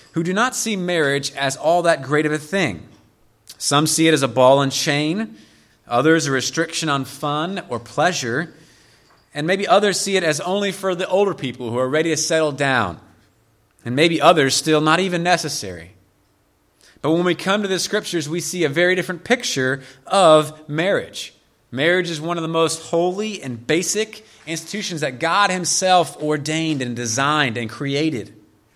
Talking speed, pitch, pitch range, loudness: 175 wpm, 155 Hz, 130-175 Hz, -19 LUFS